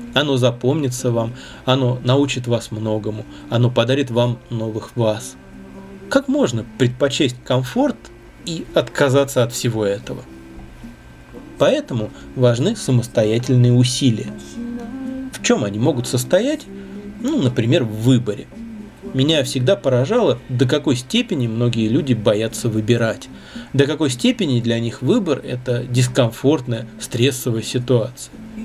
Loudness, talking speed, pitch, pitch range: -19 LUFS, 115 wpm, 125 Hz, 115-140 Hz